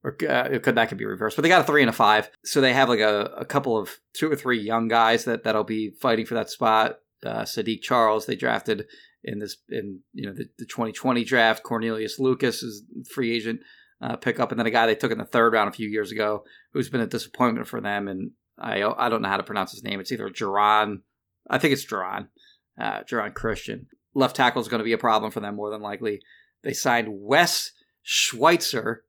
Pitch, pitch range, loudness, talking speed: 110 Hz, 105-115 Hz, -24 LUFS, 235 wpm